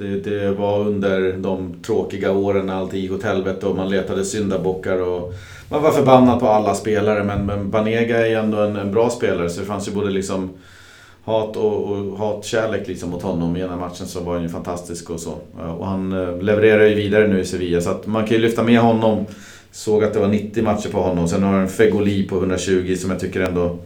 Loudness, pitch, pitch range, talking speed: -19 LUFS, 100 Hz, 95-105 Hz, 225 wpm